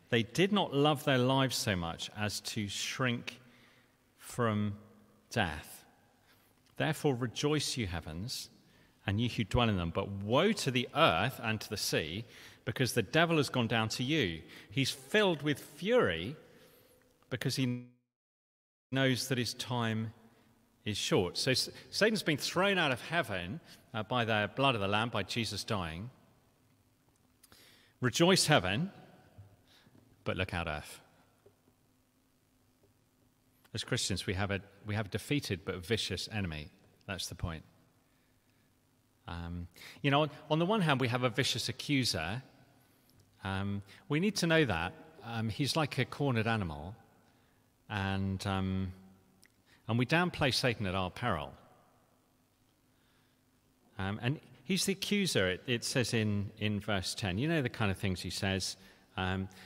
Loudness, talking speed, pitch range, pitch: -33 LUFS, 145 wpm, 100-130 Hz, 120 Hz